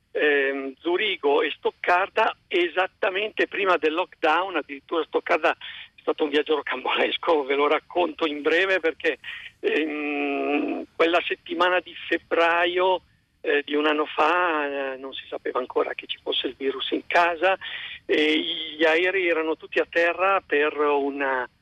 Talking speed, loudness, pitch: 135 wpm, -24 LUFS, 175 Hz